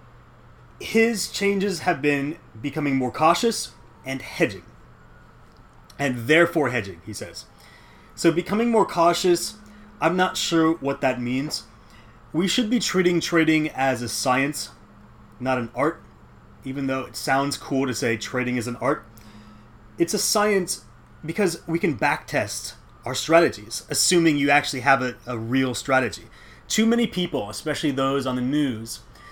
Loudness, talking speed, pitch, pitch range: -23 LUFS, 145 wpm, 140 Hz, 120-170 Hz